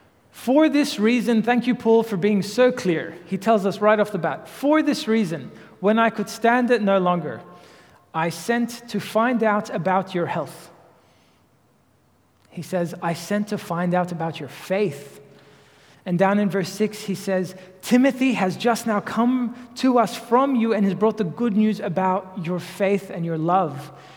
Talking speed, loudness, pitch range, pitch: 180 wpm, -22 LUFS, 180-230 Hz, 200 Hz